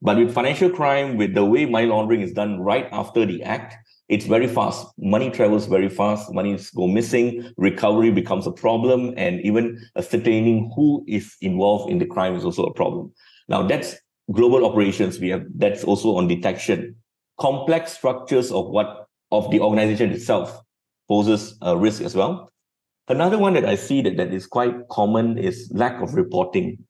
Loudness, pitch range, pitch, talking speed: -21 LUFS, 105-120 Hz, 115 Hz, 175 wpm